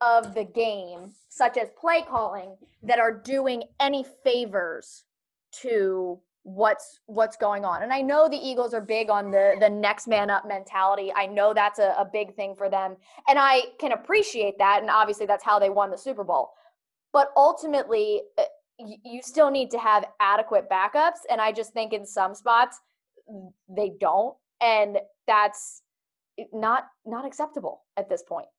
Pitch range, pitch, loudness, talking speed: 205-275 Hz, 225 Hz, -24 LUFS, 170 wpm